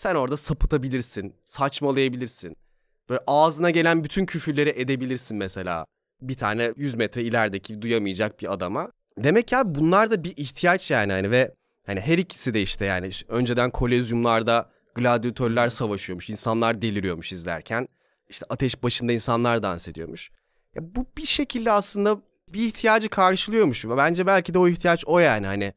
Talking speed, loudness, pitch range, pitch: 150 wpm, -23 LUFS, 110-165 Hz, 125 Hz